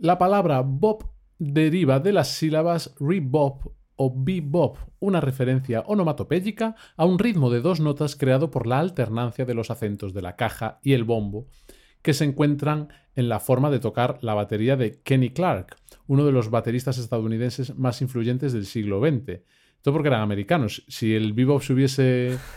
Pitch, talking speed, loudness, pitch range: 135 Hz, 170 wpm, -23 LUFS, 120-155 Hz